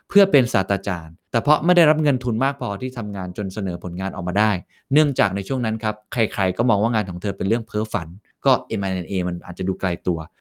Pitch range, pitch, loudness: 95-120 Hz, 105 Hz, -21 LUFS